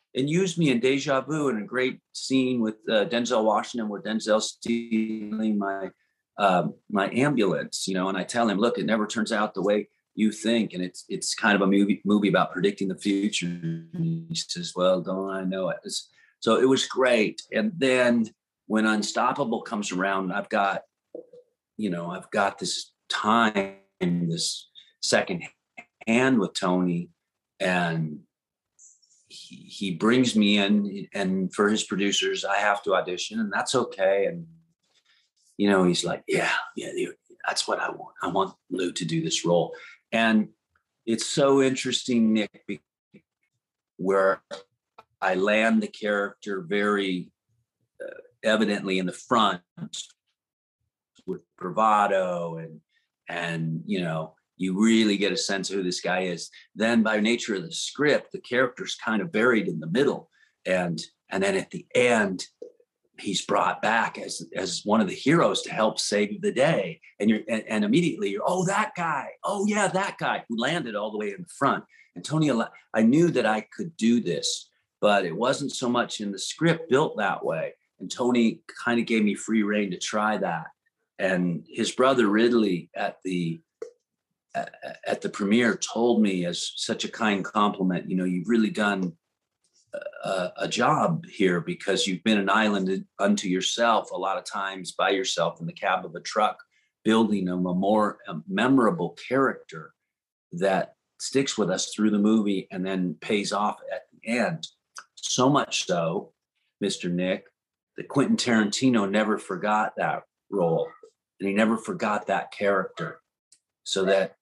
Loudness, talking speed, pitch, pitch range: -25 LUFS, 165 wpm, 110 Hz, 95-130 Hz